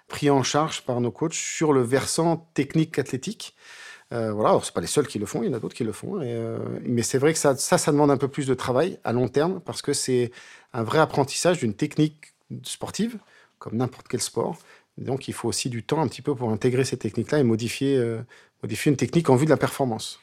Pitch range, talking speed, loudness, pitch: 120-150 Hz, 255 wpm, -24 LUFS, 135 Hz